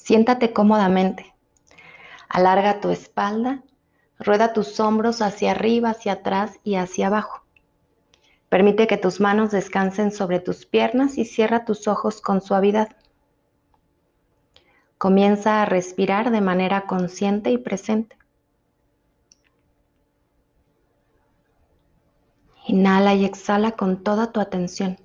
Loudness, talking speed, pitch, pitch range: -20 LUFS, 105 wpm, 205 Hz, 195-220 Hz